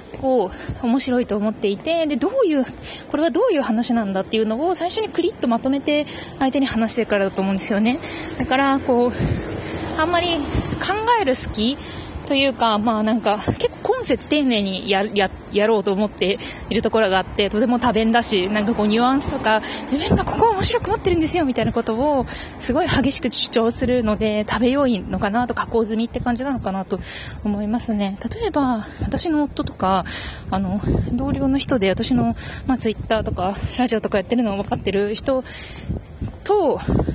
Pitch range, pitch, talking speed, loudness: 215-280 Hz, 240 Hz, 360 characters per minute, -20 LUFS